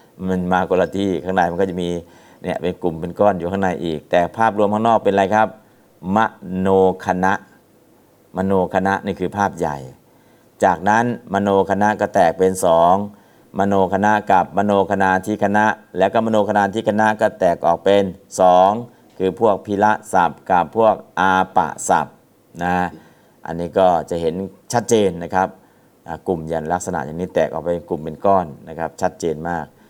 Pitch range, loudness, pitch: 90-100 Hz, -18 LUFS, 95 Hz